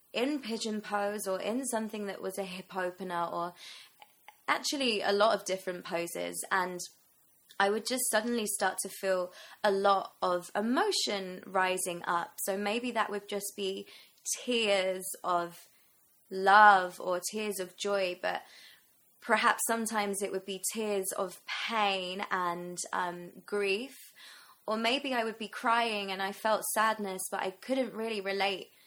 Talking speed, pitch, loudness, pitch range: 150 wpm, 200 Hz, -31 LUFS, 185-215 Hz